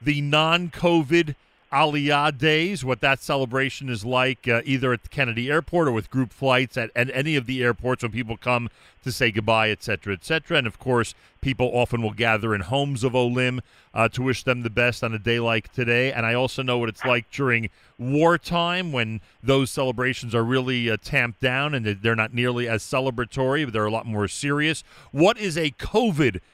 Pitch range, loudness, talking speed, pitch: 115-140 Hz, -23 LUFS, 200 wpm, 125 Hz